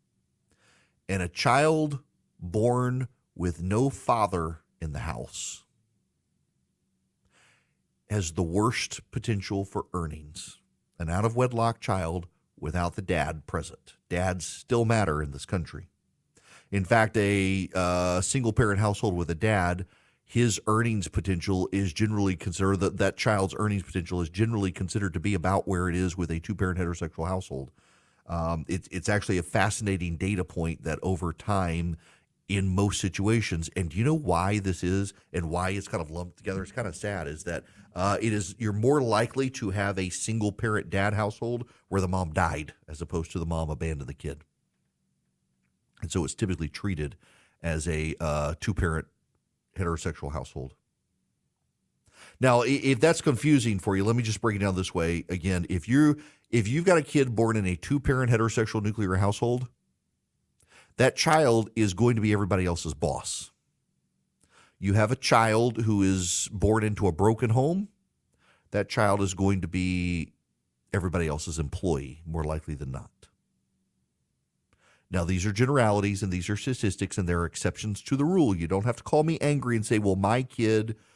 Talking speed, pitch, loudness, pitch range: 170 wpm, 95 Hz, -28 LUFS, 85-110 Hz